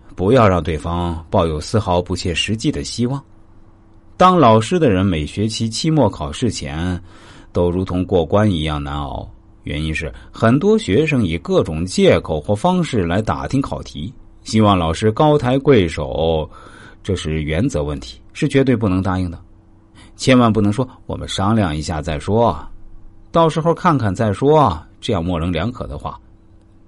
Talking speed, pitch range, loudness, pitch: 240 characters per minute, 85-115 Hz, -17 LUFS, 100 Hz